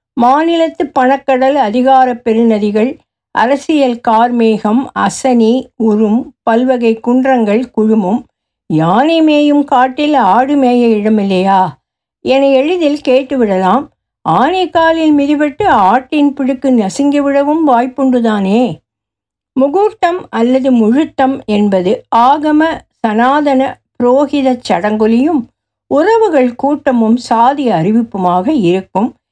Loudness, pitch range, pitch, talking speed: -11 LUFS, 225-285 Hz, 255 Hz, 80 wpm